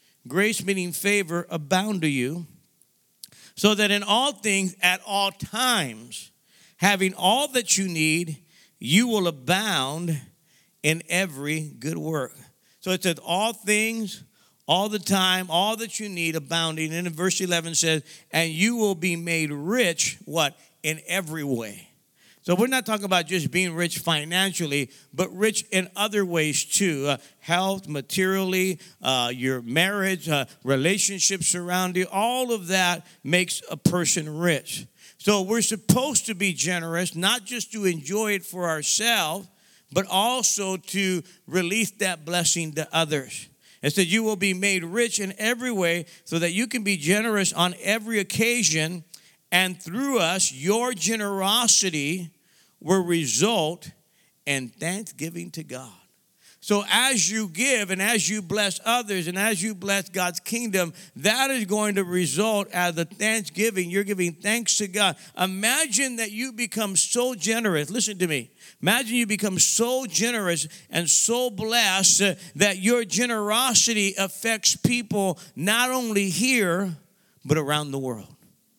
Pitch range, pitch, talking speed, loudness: 165-210 Hz, 185 Hz, 150 wpm, -23 LUFS